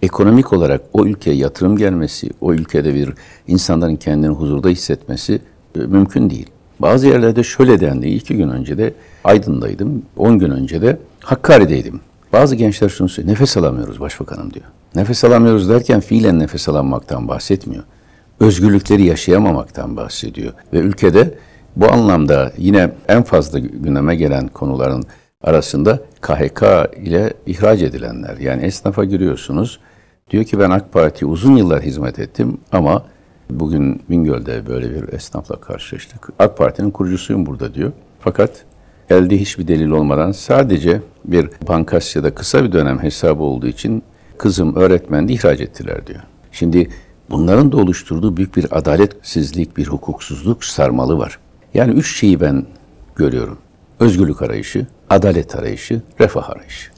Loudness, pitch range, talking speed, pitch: -14 LUFS, 75-105 Hz, 135 wpm, 90 Hz